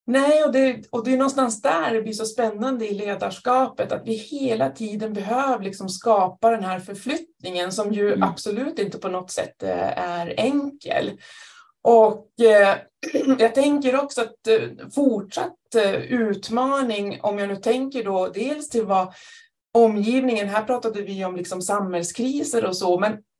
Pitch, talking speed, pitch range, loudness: 225 Hz, 150 wpm, 205-265 Hz, -22 LUFS